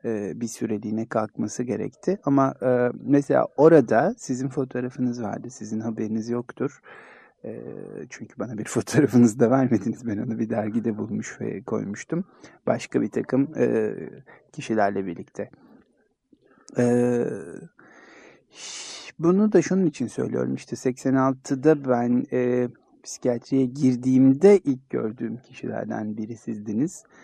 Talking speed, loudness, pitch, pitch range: 100 wpm, -24 LUFS, 125 Hz, 115-135 Hz